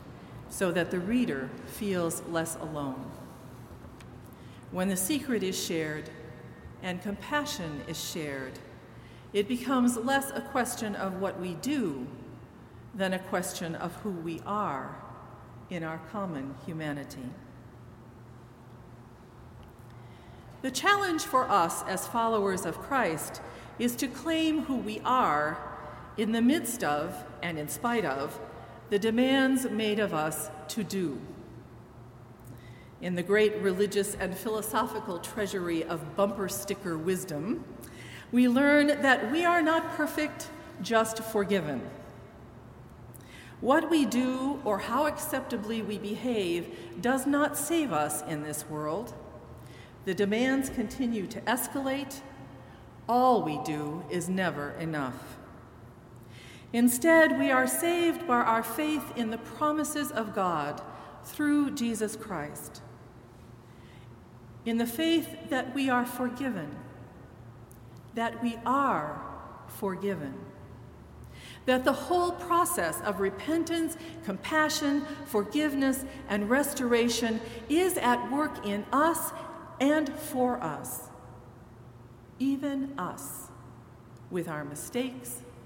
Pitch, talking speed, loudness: 200 Hz, 110 wpm, -29 LUFS